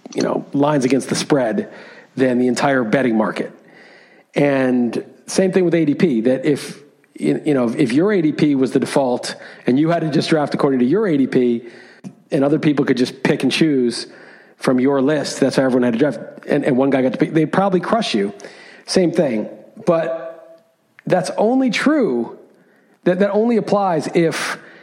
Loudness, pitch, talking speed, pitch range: -17 LUFS, 150 Hz, 180 wpm, 130-170 Hz